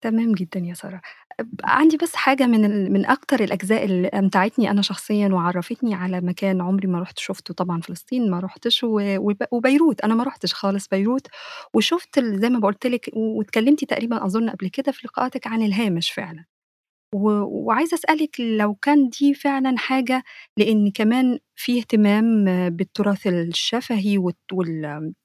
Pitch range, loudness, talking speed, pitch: 195-250 Hz, -21 LUFS, 155 wpm, 215 Hz